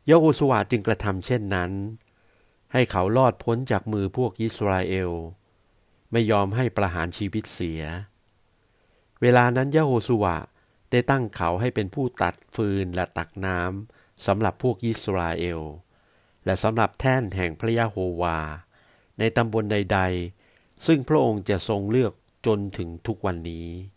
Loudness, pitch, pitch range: -24 LUFS, 105 Hz, 90-115 Hz